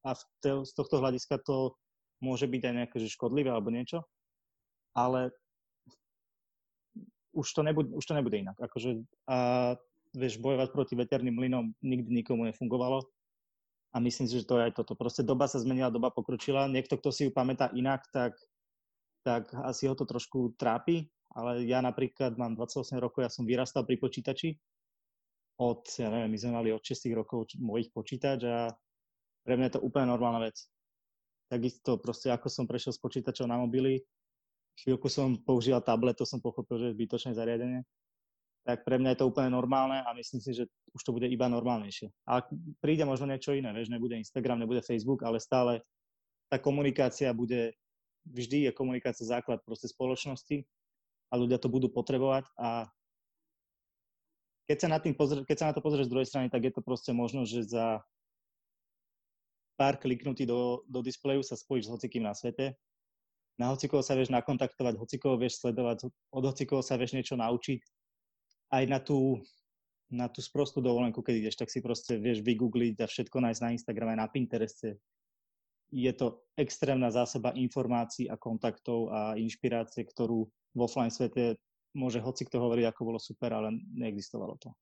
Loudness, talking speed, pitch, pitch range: -33 LUFS, 170 wpm, 125 Hz, 120-135 Hz